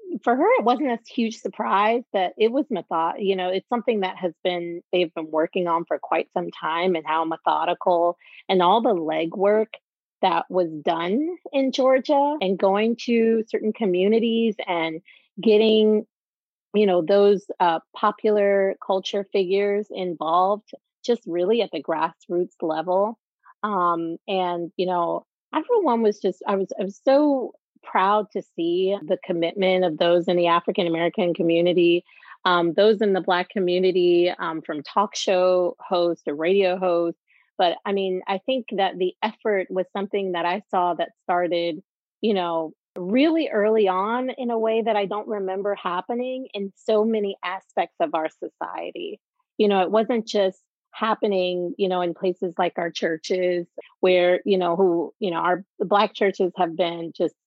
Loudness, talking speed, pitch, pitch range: -23 LUFS, 165 wpm, 190 Hz, 175-215 Hz